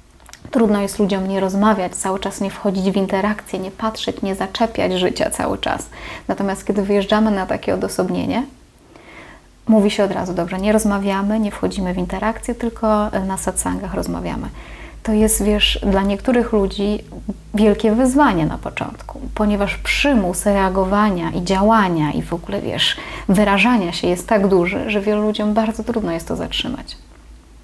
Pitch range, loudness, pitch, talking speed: 190-220 Hz, -18 LUFS, 205 Hz, 155 wpm